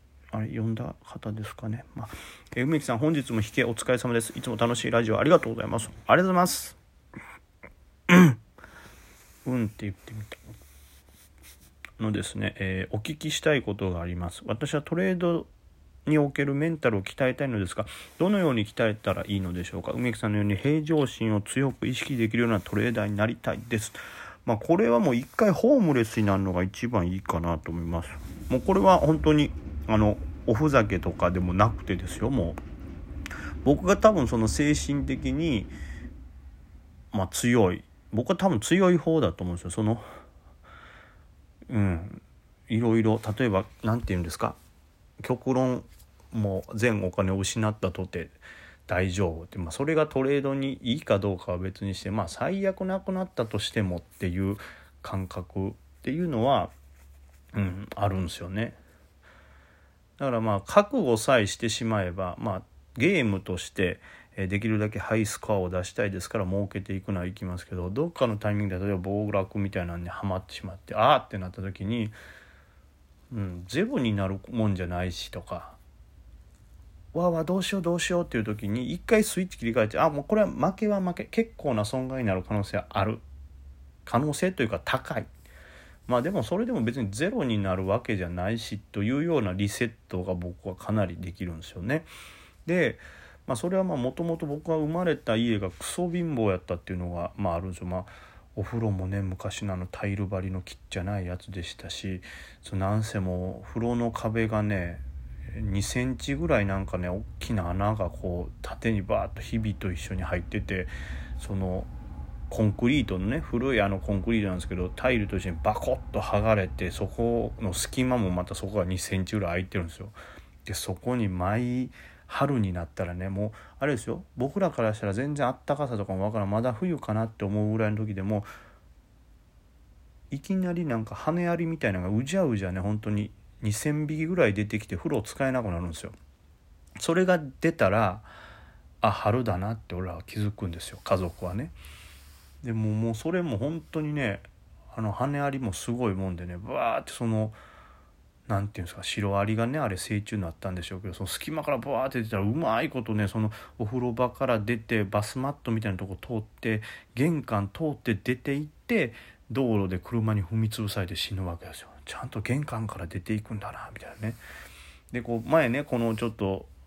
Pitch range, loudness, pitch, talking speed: 90-120 Hz, -28 LUFS, 105 Hz, 370 characters per minute